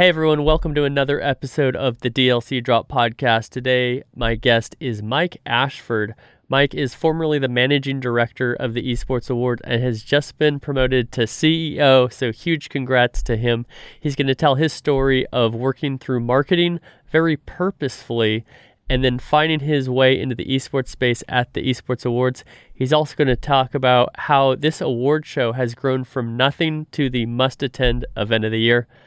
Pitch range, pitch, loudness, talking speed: 120-145 Hz, 130 Hz, -19 LUFS, 180 wpm